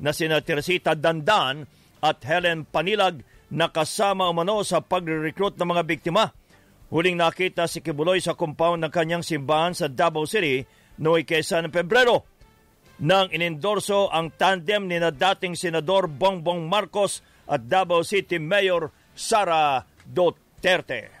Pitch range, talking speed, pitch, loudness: 160-190 Hz, 125 wpm, 170 Hz, -23 LUFS